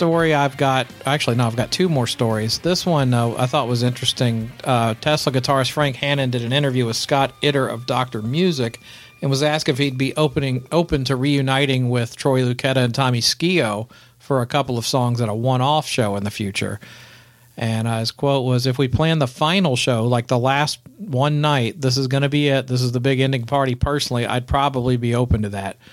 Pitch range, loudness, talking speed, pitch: 120-140 Hz, -19 LUFS, 220 wpm, 130 Hz